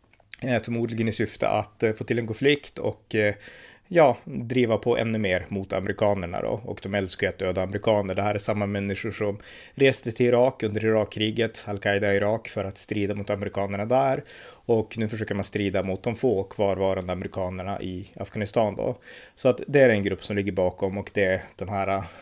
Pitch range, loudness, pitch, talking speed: 100-115 Hz, -25 LUFS, 105 Hz, 190 wpm